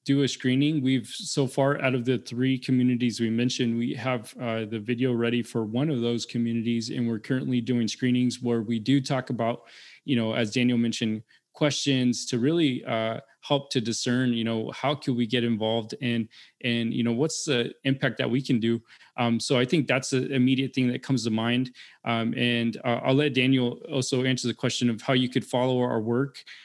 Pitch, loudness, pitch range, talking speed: 125 Hz, -26 LUFS, 115-130 Hz, 210 wpm